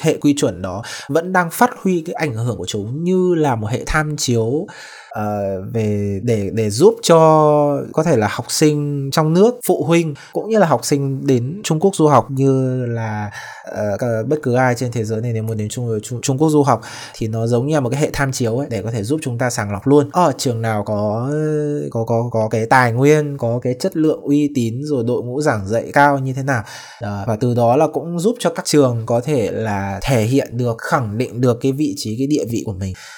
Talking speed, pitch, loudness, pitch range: 245 wpm, 130 Hz, -17 LUFS, 115-150 Hz